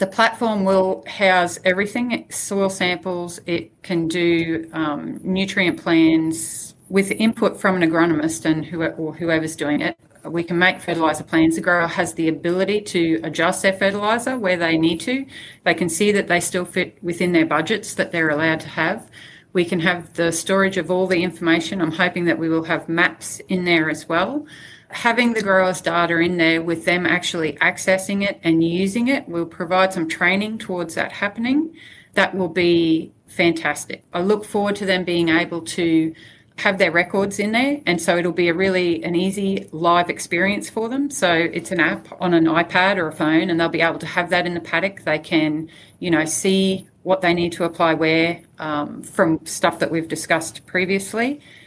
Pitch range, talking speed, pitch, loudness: 165-190 Hz, 195 wpm, 175 Hz, -19 LUFS